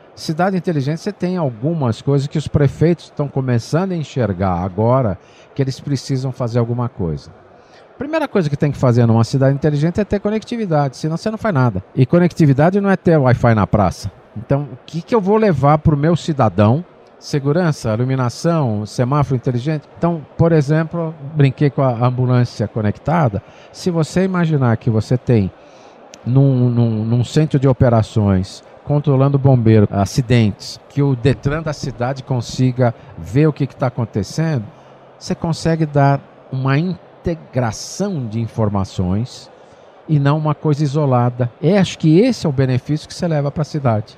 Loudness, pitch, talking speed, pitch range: -17 LUFS, 140 Hz, 165 wpm, 120-160 Hz